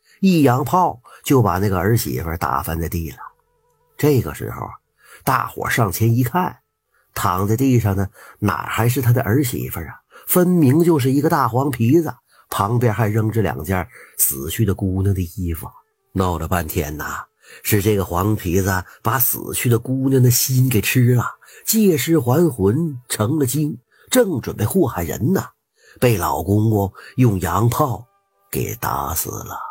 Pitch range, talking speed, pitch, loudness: 100-140 Hz, 225 characters per minute, 120 Hz, -19 LUFS